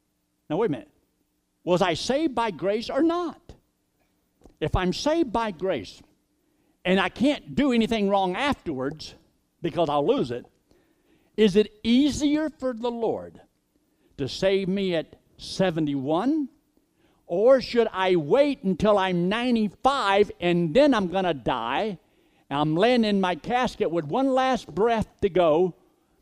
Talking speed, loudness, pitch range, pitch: 145 wpm, -24 LUFS, 180-255 Hz, 210 Hz